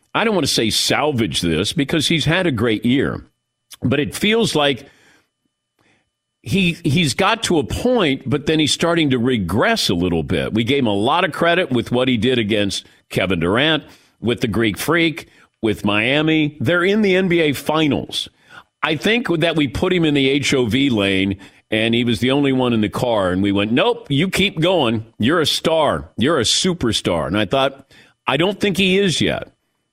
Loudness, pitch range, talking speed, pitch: -17 LUFS, 115-170 Hz, 195 wpm, 140 Hz